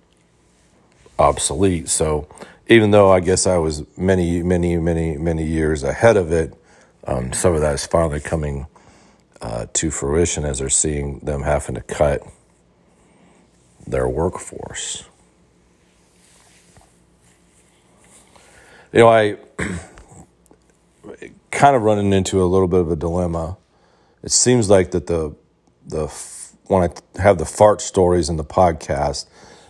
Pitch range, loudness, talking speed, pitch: 65-90 Hz, -18 LUFS, 125 wpm, 80 Hz